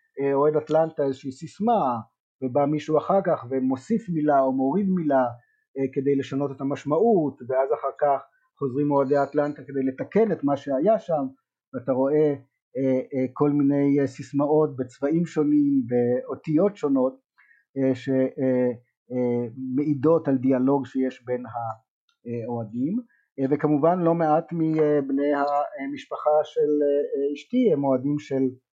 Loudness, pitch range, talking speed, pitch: -24 LUFS, 130-155 Hz, 130 wpm, 140 Hz